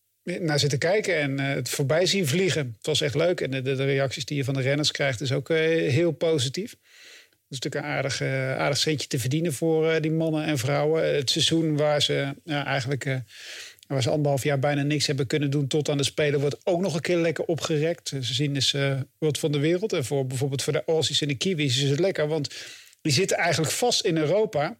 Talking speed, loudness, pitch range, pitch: 220 wpm, -25 LUFS, 140-160 Hz, 150 Hz